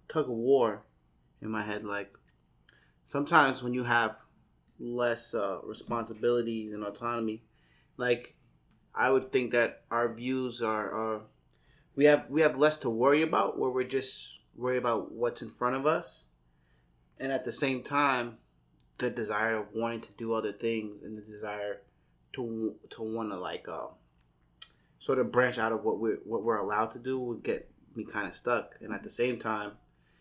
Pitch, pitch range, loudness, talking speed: 115 Hz, 105-125 Hz, -31 LUFS, 175 wpm